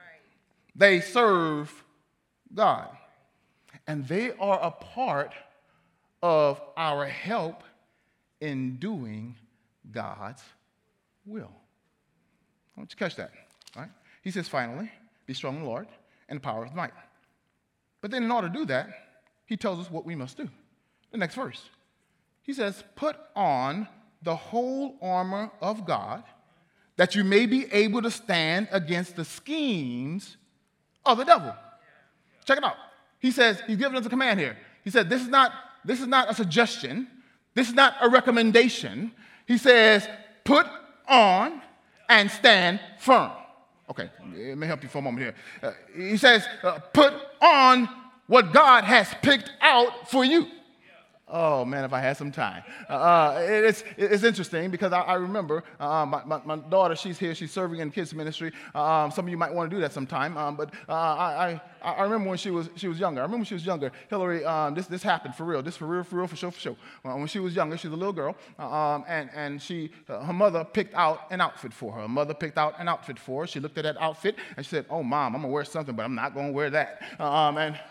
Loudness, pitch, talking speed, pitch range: -24 LUFS, 185 Hz, 195 wpm, 155-230 Hz